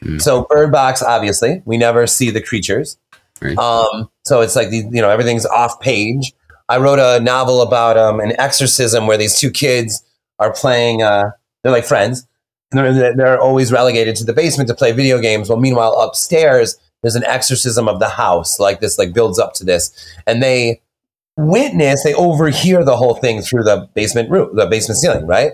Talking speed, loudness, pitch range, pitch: 190 wpm, -13 LUFS, 115-130 Hz, 120 Hz